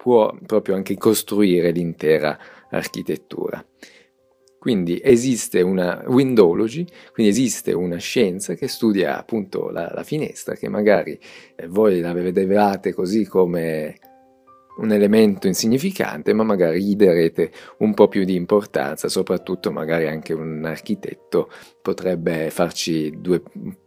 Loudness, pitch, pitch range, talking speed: -20 LUFS, 100 Hz, 85-130 Hz, 120 wpm